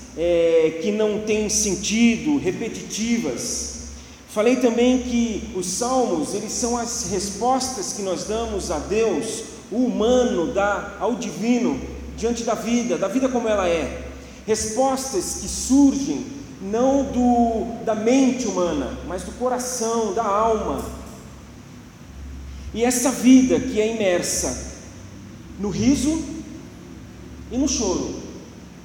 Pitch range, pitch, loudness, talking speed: 200-250 Hz, 230 Hz, -21 LUFS, 120 wpm